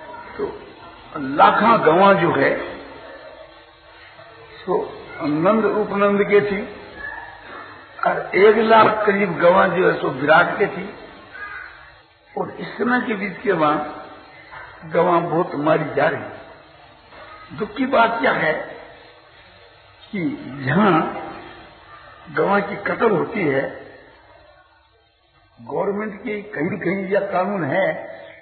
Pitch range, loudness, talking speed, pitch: 195-265 Hz, -19 LUFS, 110 wpm, 210 Hz